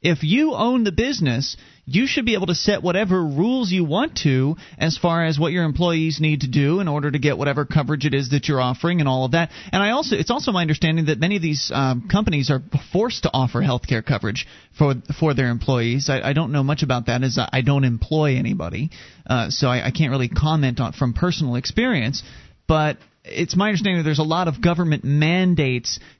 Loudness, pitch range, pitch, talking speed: -20 LUFS, 135-175 Hz, 155 Hz, 225 wpm